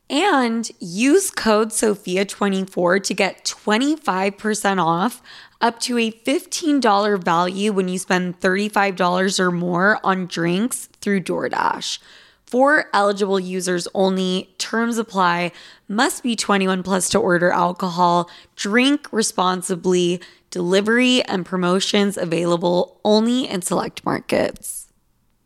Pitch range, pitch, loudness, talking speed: 180-225 Hz, 195 Hz, -19 LUFS, 110 wpm